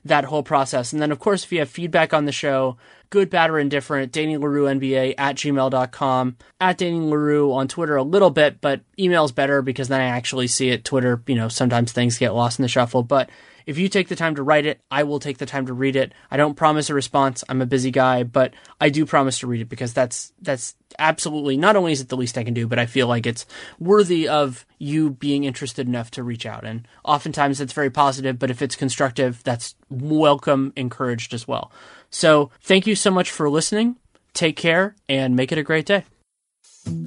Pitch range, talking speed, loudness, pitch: 130-155 Hz, 225 wpm, -20 LUFS, 140 Hz